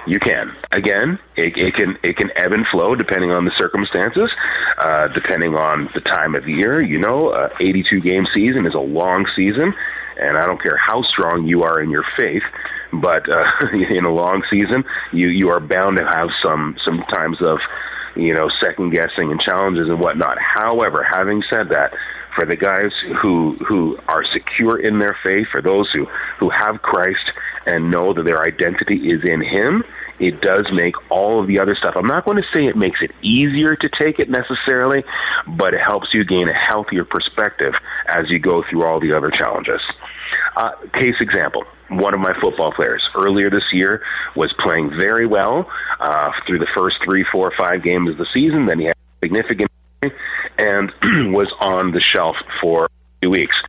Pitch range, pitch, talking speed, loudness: 85-105 Hz, 95 Hz, 195 wpm, -16 LUFS